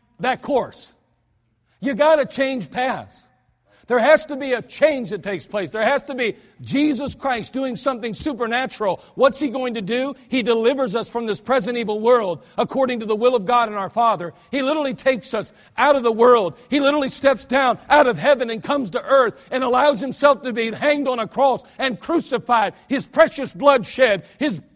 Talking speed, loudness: 200 wpm, -20 LUFS